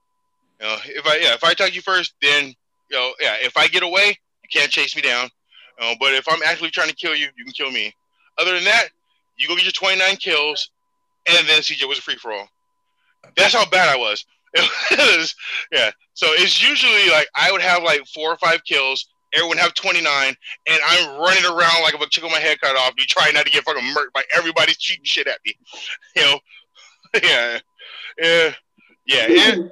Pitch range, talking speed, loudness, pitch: 150-250 Hz, 220 wpm, -16 LUFS, 170 Hz